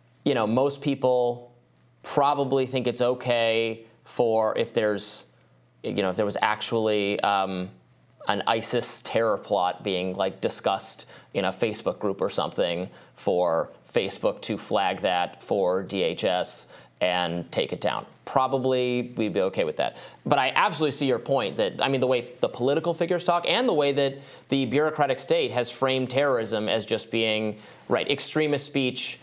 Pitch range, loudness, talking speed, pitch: 110-140 Hz, -25 LUFS, 160 wpm, 125 Hz